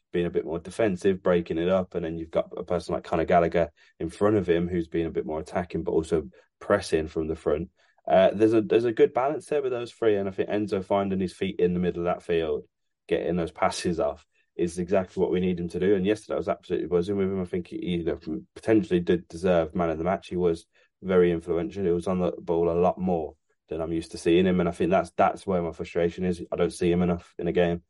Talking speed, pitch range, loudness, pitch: 265 wpm, 85-100 Hz, -26 LUFS, 90 Hz